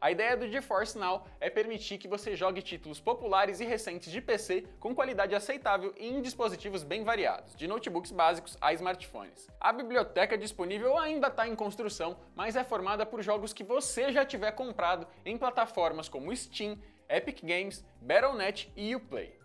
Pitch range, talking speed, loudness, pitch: 190-245 Hz, 165 wpm, -33 LUFS, 210 Hz